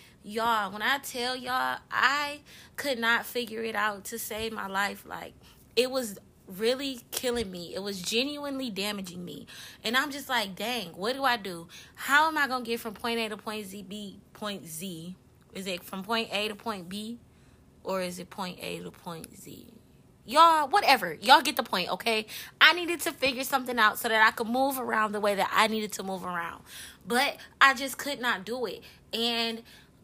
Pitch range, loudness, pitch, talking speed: 200-255 Hz, -28 LUFS, 225 Hz, 200 wpm